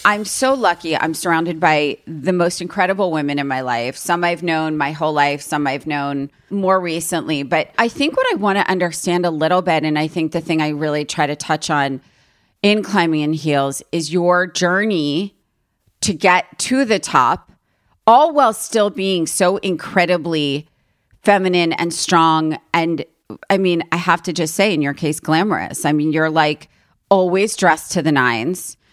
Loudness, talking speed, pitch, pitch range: -17 LUFS, 185 wpm, 165 Hz, 150-185 Hz